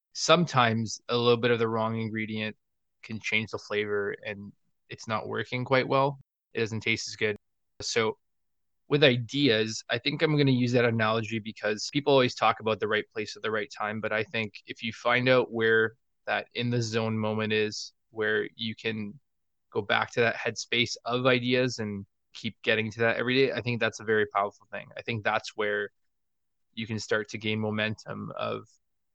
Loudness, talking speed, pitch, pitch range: -28 LUFS, 195 wpm, 110 Hz, 110-120 Hz